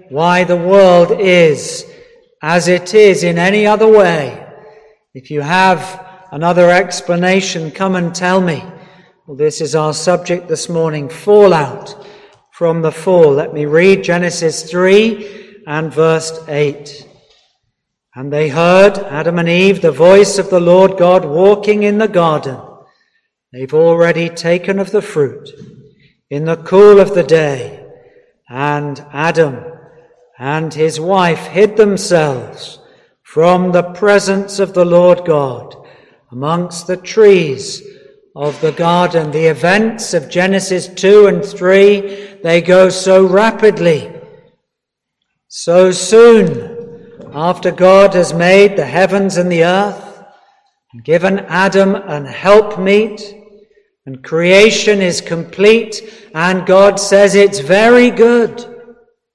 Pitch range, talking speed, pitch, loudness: 165-205 Hz, 125 wpm, 185 Hz, -11 LUFS